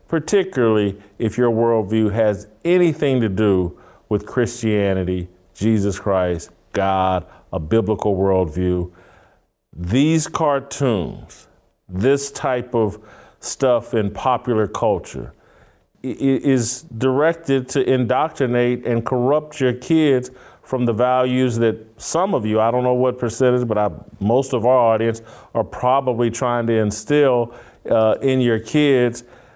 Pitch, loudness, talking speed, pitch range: 115 Hz, -19 LUFS, 120 wpm, 105-130 Hz